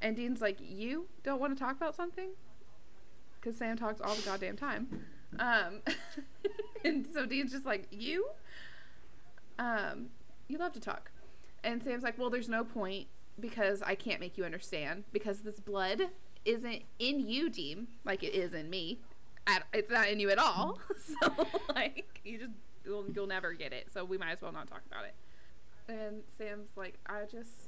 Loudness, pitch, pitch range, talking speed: -37 LUFS, 225 Hz, 205-280 Hz, 180 wpm